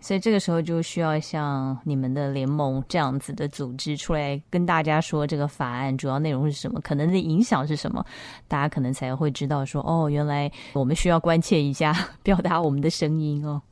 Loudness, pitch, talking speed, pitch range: -25 LUFS, 150 Hz, 325 characters per minute, 140-165 Hz